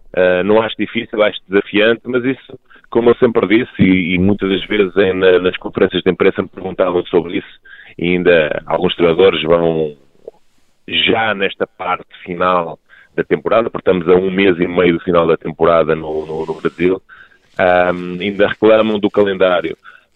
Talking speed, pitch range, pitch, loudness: 175 wpm, 90-105 Hz, 90 Hz, -14 LUFS